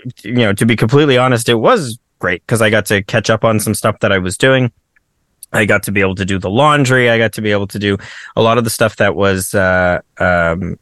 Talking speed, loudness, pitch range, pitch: 260 wpm, -13 LUFS, 100-120 Hz, 110 Hz